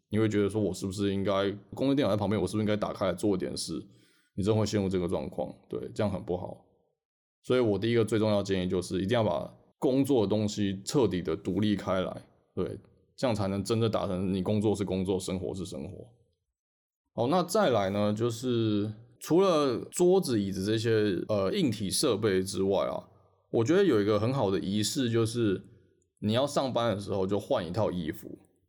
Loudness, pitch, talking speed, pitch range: -29 LUFS, 105 Hz, 305 characters per minute, 95-115 Hz